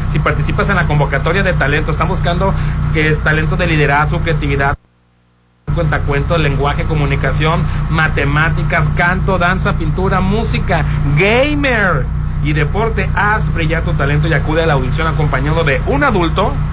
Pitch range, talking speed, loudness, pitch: 140-155 Hz, 145 wpm, -14 LUFS, 145 Hz